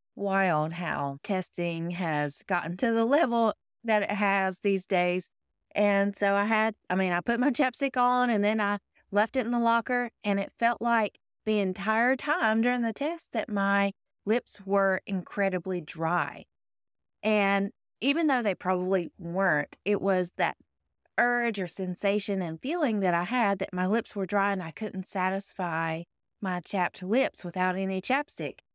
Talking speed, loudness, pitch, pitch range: 165 wpm, -28 LUFS, 200 Hz, 185-230 Hz